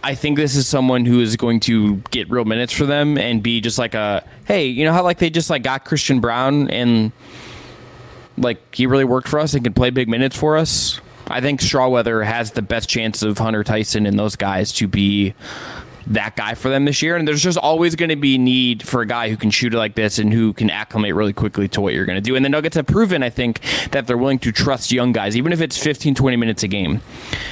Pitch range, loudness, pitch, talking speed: 110-140 Hz, -17 LUFS, 120 Hz, 255 wpm